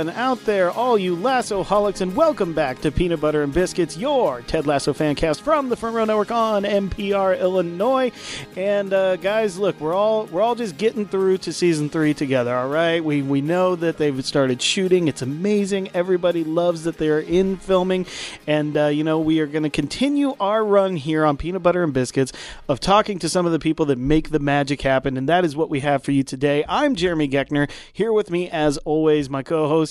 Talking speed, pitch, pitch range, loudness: 215 wpm, 170 Hz, 150-200 Hz, -20 LUFS